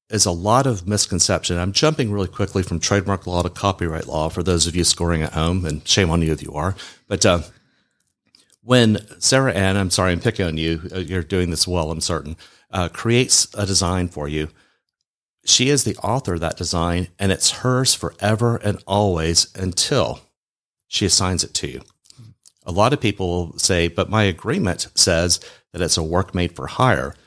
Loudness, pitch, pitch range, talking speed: -19 LUFS, 90 Hz, 85-105 Hz, 195 wpm